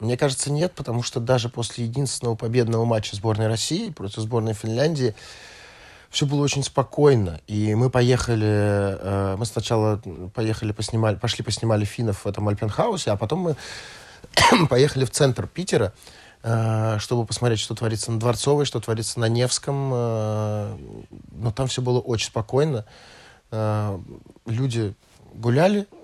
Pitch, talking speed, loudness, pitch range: 115 Hz, 140 wpm, -23 LUFS, 110-125 Hz